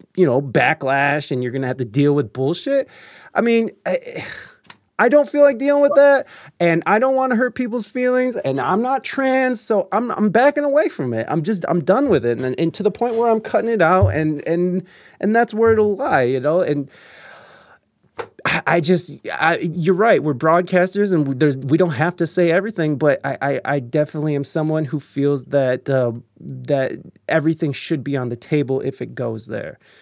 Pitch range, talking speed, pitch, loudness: 140-225 Hz, 210 wpm, 165 Hz, -18 LUFS